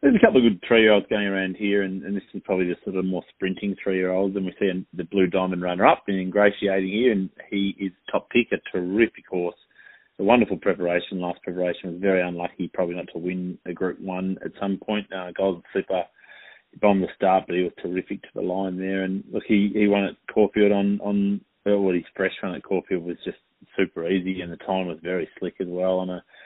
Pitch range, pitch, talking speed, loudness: 90-100 Hz, 95 Hz, 225 wpm, -24 LUFS